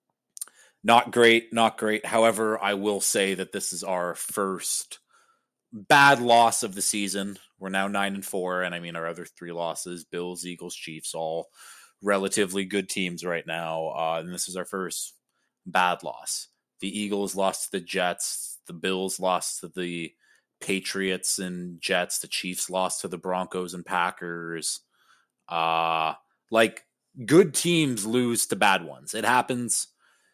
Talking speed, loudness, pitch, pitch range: 155 wpm, -25 LUFS, 95 Hz, 85-105 Hz